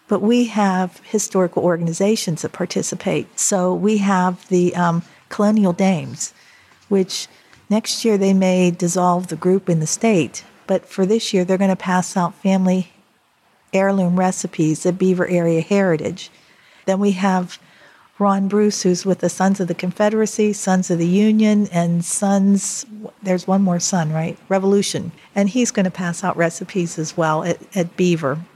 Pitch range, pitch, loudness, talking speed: 175-200 Hz, 185 Hz, -18 LUFS, 160 wpm